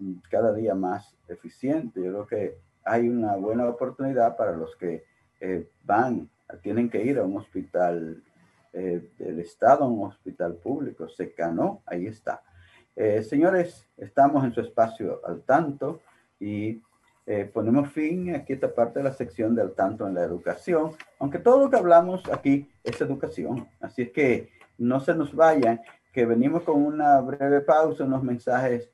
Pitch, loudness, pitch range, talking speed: 120 Hz, -25 LUFS, 105-145 Hz, 165 wpm